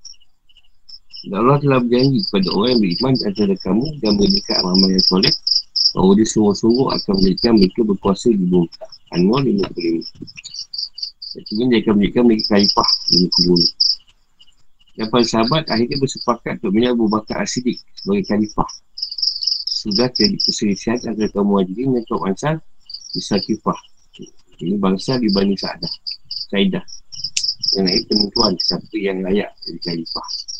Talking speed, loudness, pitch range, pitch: 145 wpm, -17 LUFS, 95-120 Hz, 105 Hz